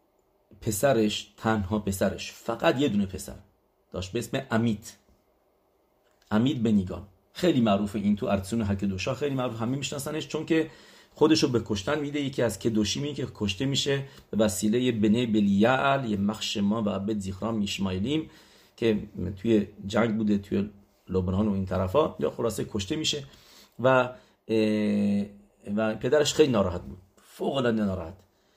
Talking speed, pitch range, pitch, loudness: 145 wpm, 100-125 Hz, 110 Hz, -27 LUFS